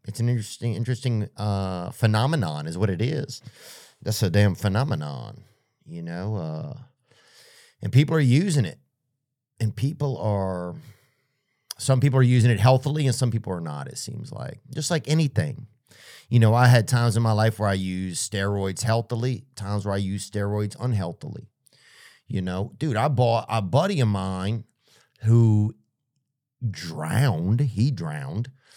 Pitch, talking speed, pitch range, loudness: 120 Hz, 155 wpm, 105-135 Hz, -24 LUFS